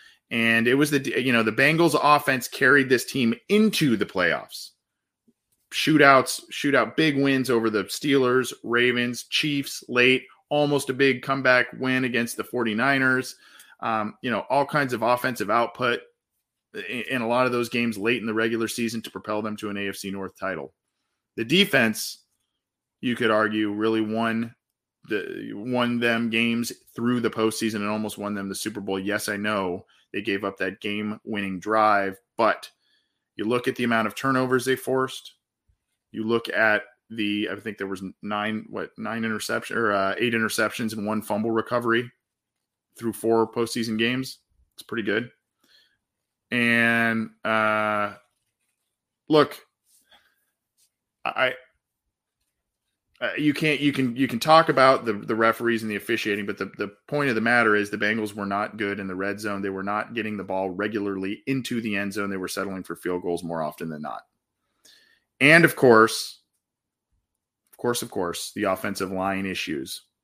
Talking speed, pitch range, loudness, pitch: 165 wpm, 105-125 Hz, -24 LUFS, 115 Hz